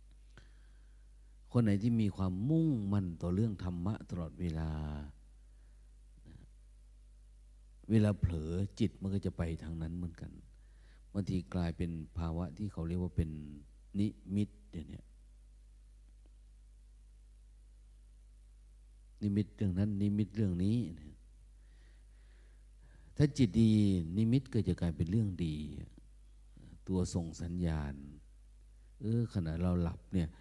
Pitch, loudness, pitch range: 85 Hz, -35 LUFS, 60-100 Hz